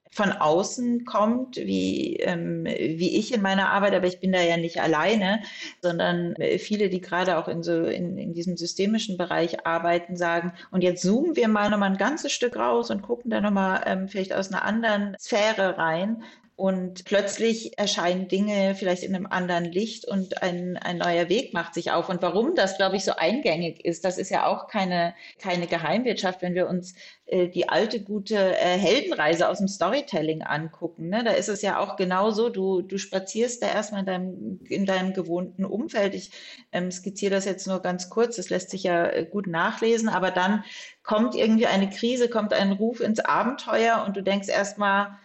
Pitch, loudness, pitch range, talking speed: 190 Hz, -25 LUFS, 180-210 Hz, 190 wpm